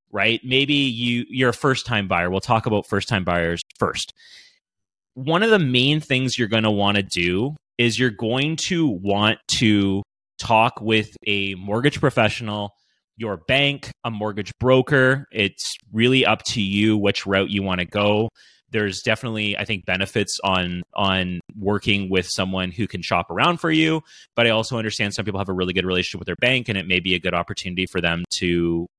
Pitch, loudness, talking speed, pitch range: 105 Hz, -21 LUFS, 195 wpm, 95-125 Hz